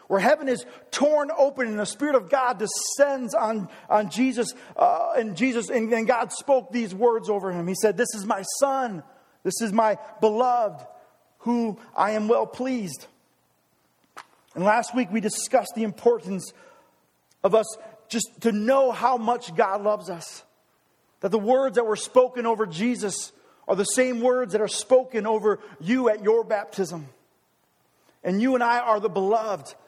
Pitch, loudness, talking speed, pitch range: 225 Hz, -24 LUFS, 170 wpm, 210-250 Hz